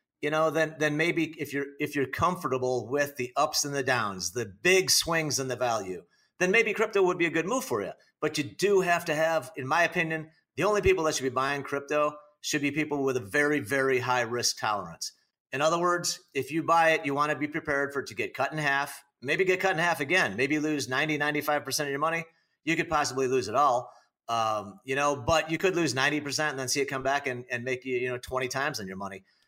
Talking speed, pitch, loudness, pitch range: 245 wpm, 150 Hz, -27 LUFS, 135-160 Hz